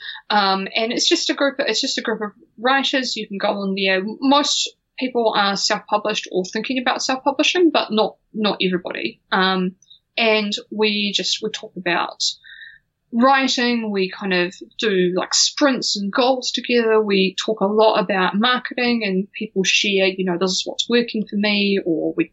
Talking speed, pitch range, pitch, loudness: 175 wpm, 195-255 Hz, 215 Hz, -19 LUFS